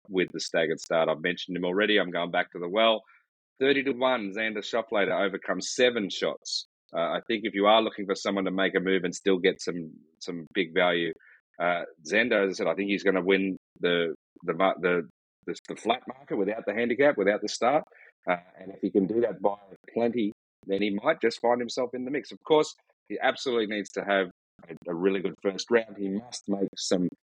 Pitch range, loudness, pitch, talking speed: 95-115 Hz, -27 LUFS, 100 Hz, 225 wpm